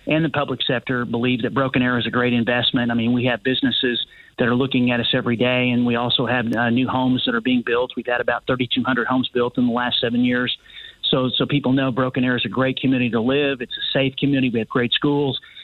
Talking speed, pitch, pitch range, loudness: 260 wpm, 125 Hz, 120-130 Hz, -20 LUFS